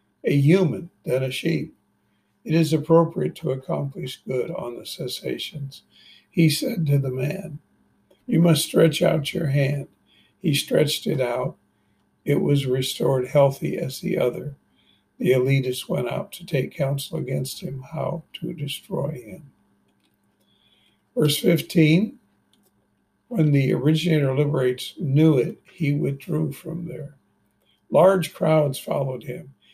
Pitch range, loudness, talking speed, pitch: 135-165 Hz, -23 LUFS, 130 wpm, 150 Hz